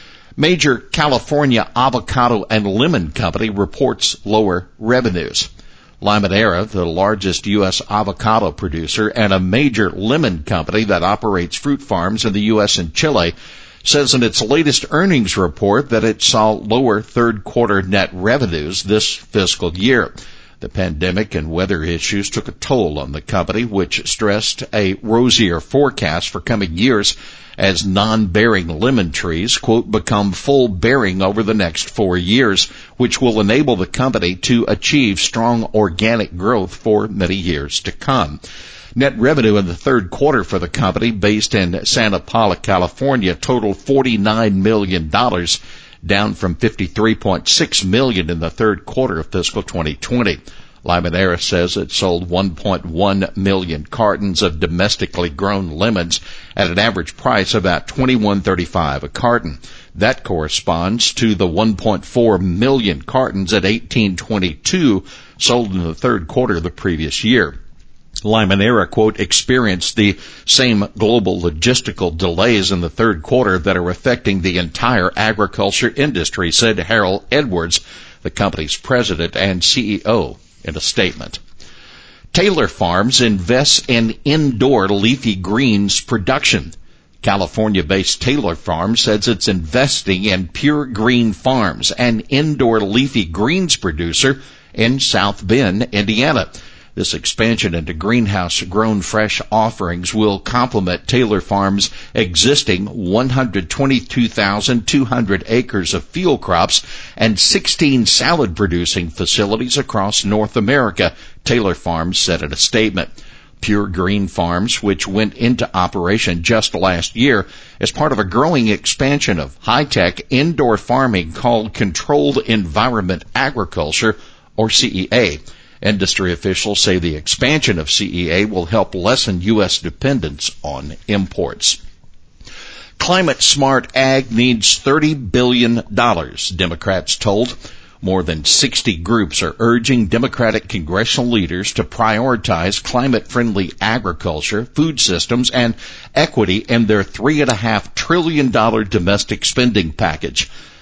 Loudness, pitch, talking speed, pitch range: -15 LUFS, 105 Hz, 130 wpm, 95-120 Hz